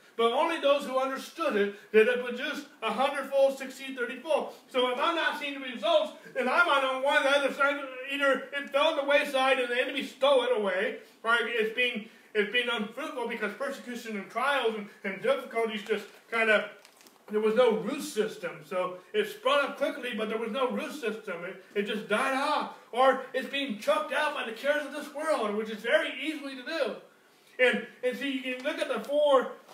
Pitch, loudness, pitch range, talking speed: 260 Hz, -29 LUFS, 225-285 Hz, 205 wpm